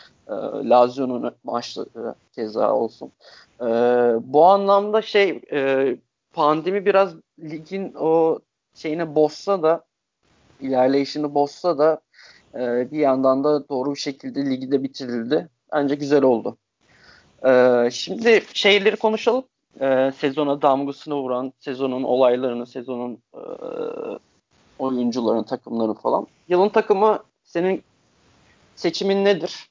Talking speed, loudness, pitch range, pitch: 95 wpm, -21 LUFS, 130-185 Hz, 145 Hz